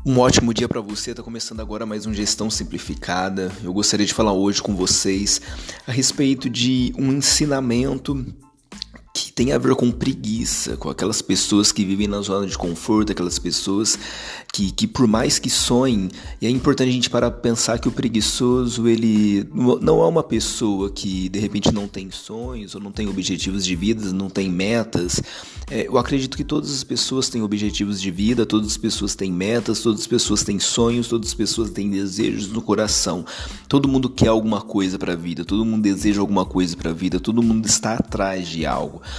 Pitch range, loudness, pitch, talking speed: 95-120 Hz, -20 LUFS, 105 Hz, 195 wpm